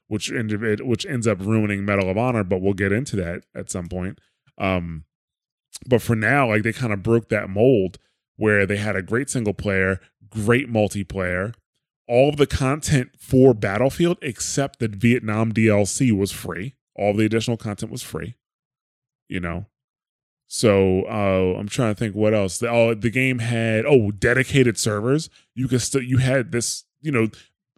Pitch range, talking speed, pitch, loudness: 100-125 Hz, 175 wpm, 110 Hz, -21 LUFS